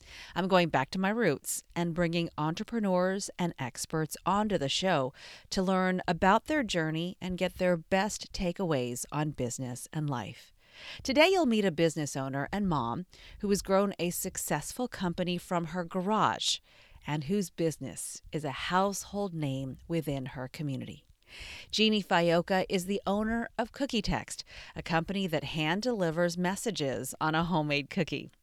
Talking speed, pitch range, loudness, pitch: 155 wpm, 155-195 Hz, -31 LUFS, 175 Hz